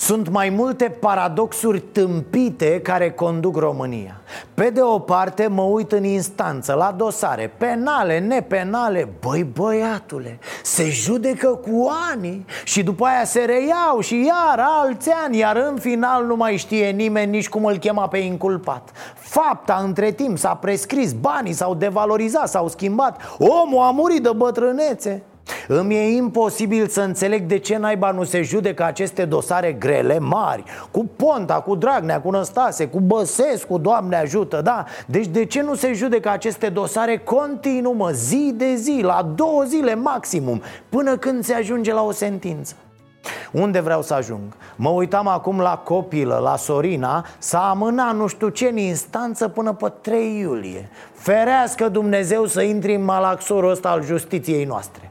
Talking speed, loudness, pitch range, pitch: 160 wpm, -19 LUFS, 180-240 Hz, 210 Hz